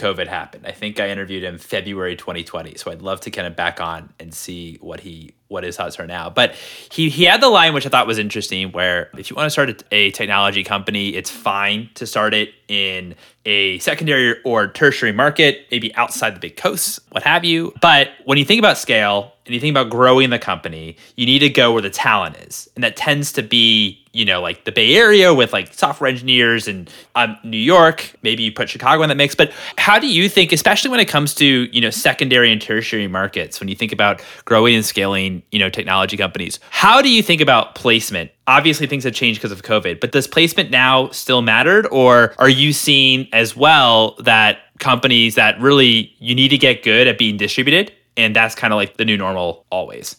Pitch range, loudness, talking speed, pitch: 100-140 Hz, -14 LUFS, 220 wpm, 115 Hz